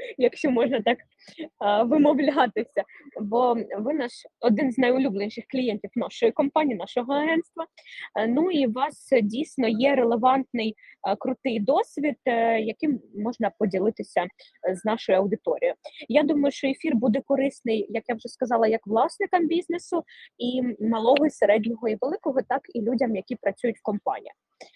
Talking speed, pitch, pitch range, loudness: 135 wpm, 250 Hz, 225-290 Hz, -25 LUFS